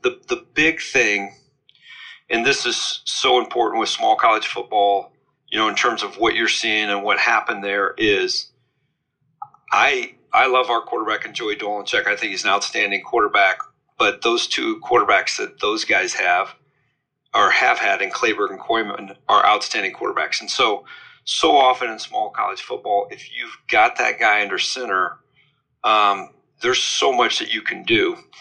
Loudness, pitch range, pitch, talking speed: -19 LUFS, 360-390 Hz, 375 Hz, 170 wpm